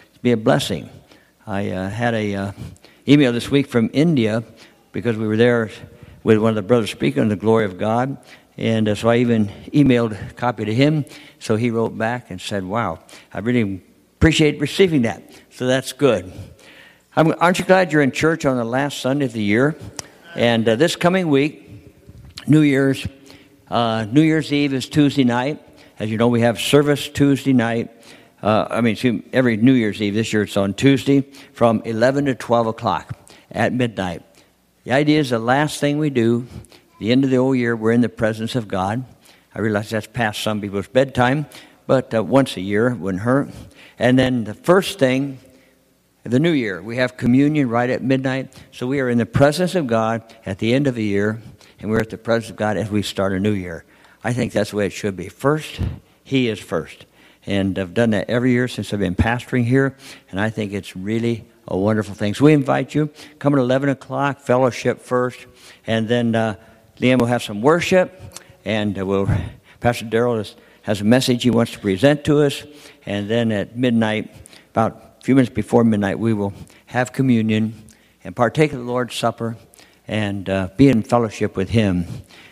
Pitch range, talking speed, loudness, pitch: 110-135 Hz, 200 wpm, -19 LUFS, 120 Hz